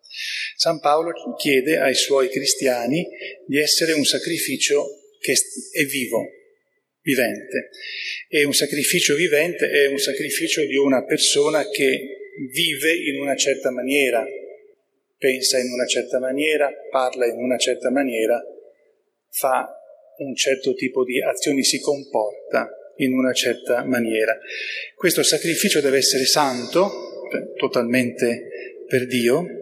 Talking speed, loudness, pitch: 120 wpm, -20 LUFS, 150 Hz